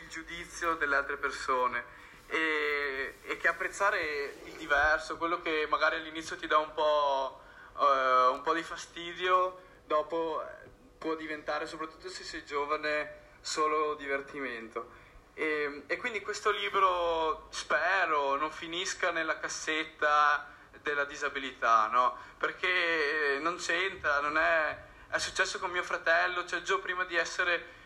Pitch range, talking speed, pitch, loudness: 145-170 Hz, 130 wpm, 155 Hz, -30 LUFS